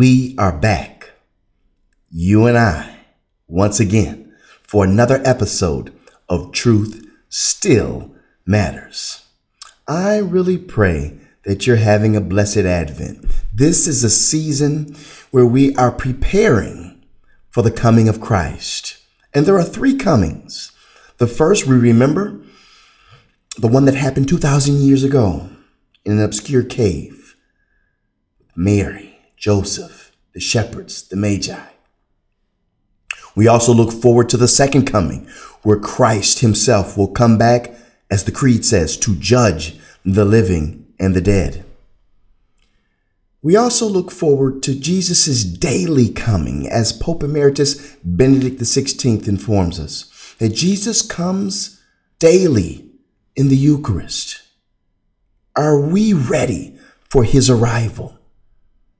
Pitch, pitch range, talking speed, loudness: 115 Hz, 100-135 Hz, 120 wpm, -15 LUFS